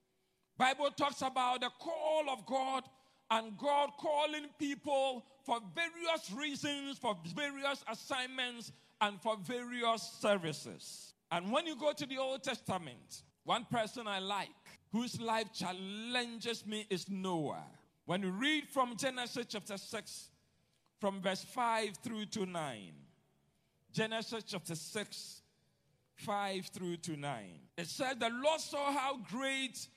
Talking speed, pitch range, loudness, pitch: 130 wpm, 195-270 Hz, -38 LUFS, 230 Hz